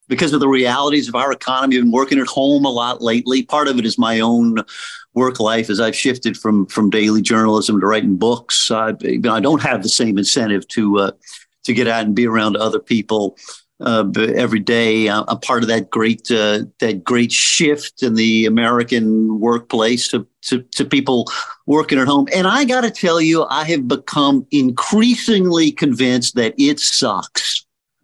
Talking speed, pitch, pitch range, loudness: 185 wpm, 120 Hz, 110-140 Hz, -16 LUFS